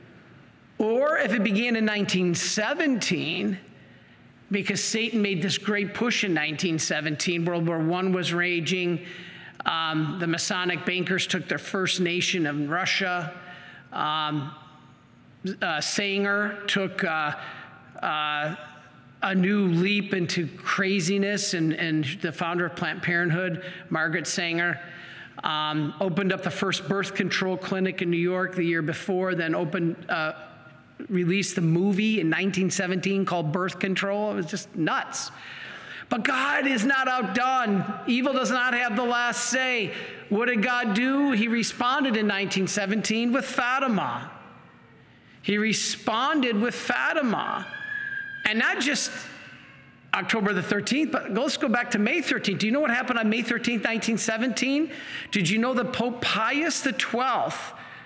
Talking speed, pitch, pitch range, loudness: 140 wpm, 195 Hz, 175-230 Hz, -25 LUFS